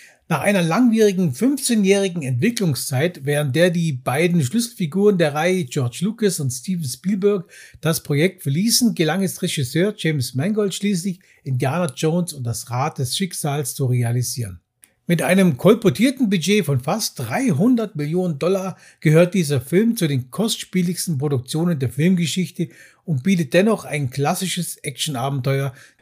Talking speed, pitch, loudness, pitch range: 135 wpm, 170 Hz, -20 LUFS, 145-195 Hz